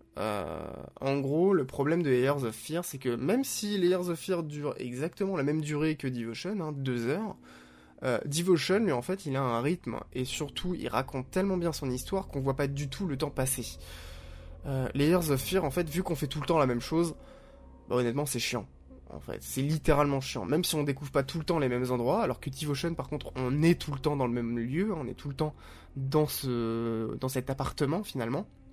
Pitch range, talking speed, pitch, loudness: 125-165 Hz, 230 wpm, 140 Hz, -31 LUFS